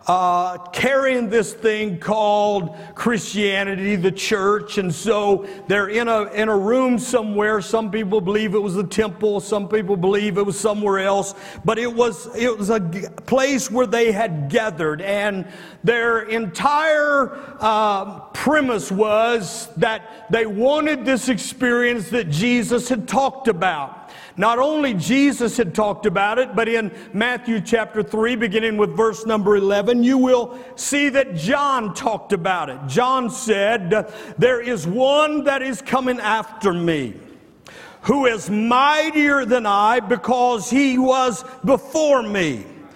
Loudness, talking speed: -19 LUFS, 145 wpm